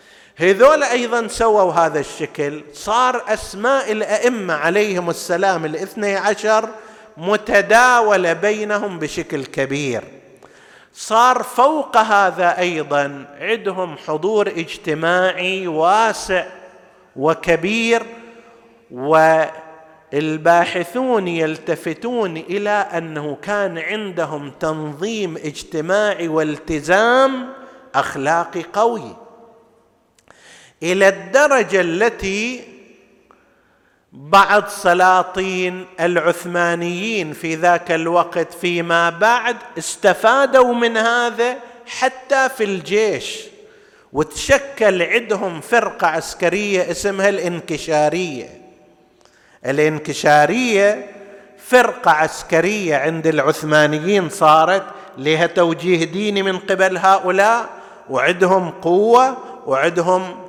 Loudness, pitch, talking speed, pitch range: -17 LUFS, 190 Hz, 75 wpm, 165-220 Hz